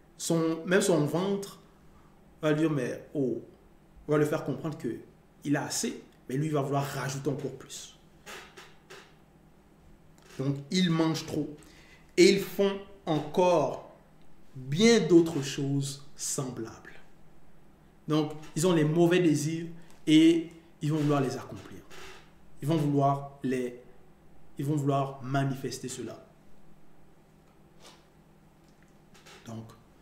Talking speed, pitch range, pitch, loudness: 120 wpm, 140-175 Hz, 165 Hz, -28 LUFS